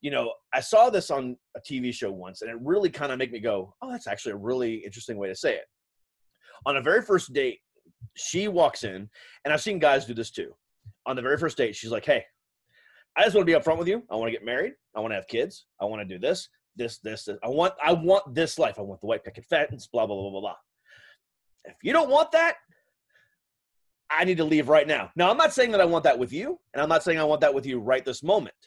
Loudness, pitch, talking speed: -25 LUFS, 150 Hz, 270 wpm